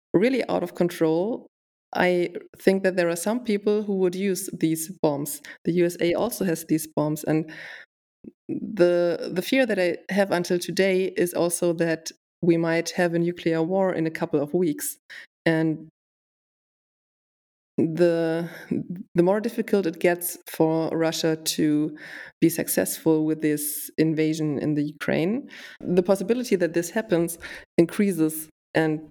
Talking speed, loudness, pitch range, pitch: 145 wpm, -24 LUFS, 160-185 Hz, 170 Hz